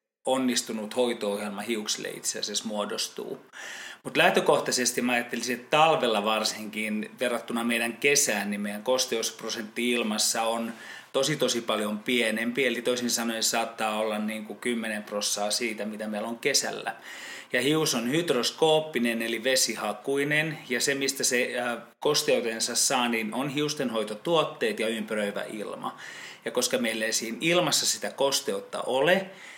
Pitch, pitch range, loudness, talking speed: 115 Hz, 110-130 Hz, -26 LUFS, 135 wpm